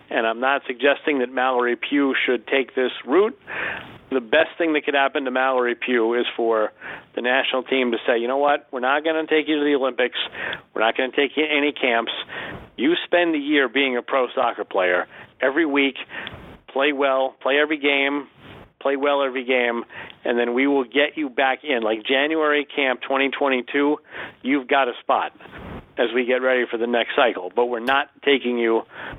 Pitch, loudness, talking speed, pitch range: 135 Hz, -21 LUFS, 200 wpm, 125-145 Hz